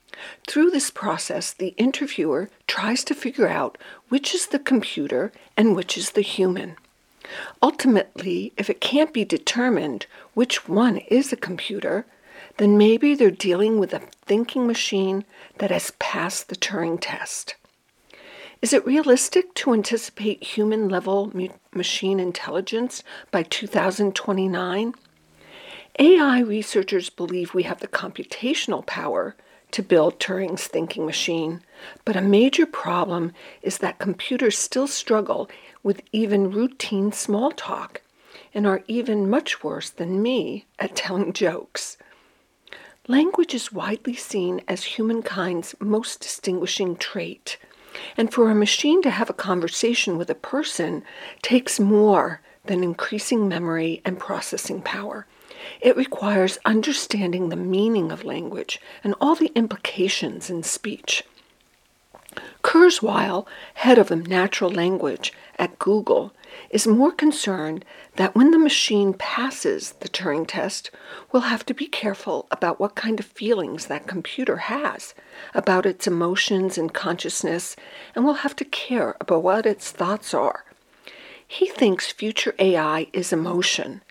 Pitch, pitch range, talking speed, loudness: 210 Hz, 190-260 Hz, 130 wpm, -22 LUFS